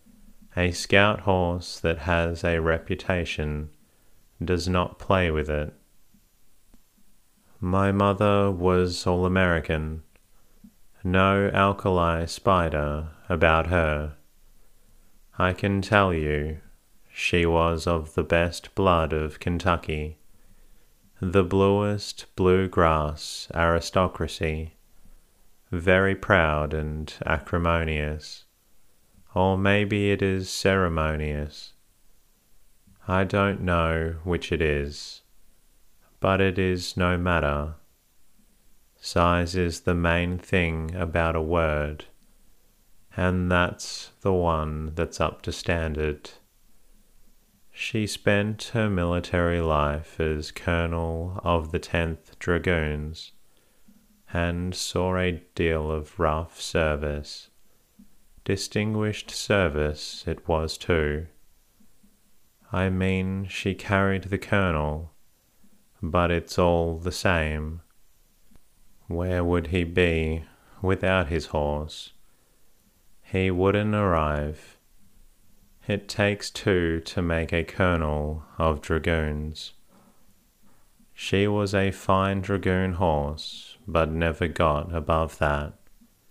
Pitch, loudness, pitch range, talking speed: 85 Hz, -25 LUFS, 80-95 Hz, 95 wpm